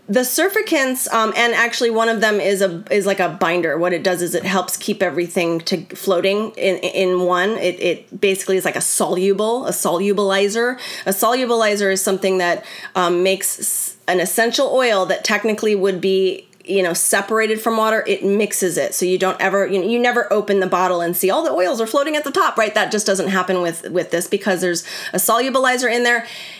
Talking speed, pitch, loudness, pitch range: 210 wpm, 195 Hz, -17 LUFS, 185-225 Hz